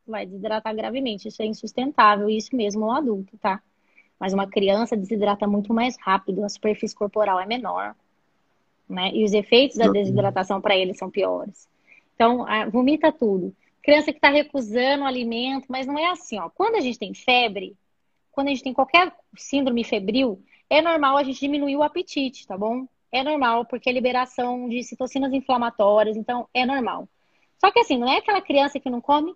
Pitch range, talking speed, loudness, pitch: 215-275 Hz, 190 wpm, -22 LUFS, 245 Hz